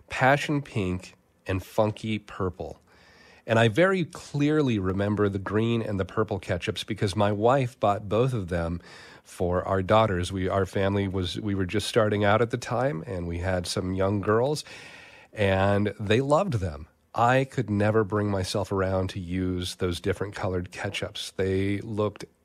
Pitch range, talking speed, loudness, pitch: 95-110 Hz, 165 wpm, -26 LUFS, 100 Hz